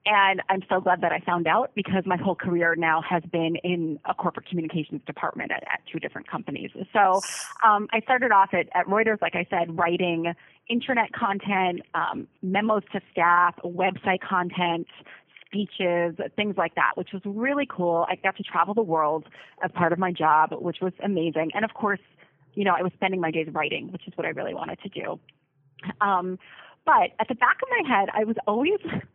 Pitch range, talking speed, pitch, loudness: 170-205 Hz, 200 wpm, 185 Hz, -25 LUFS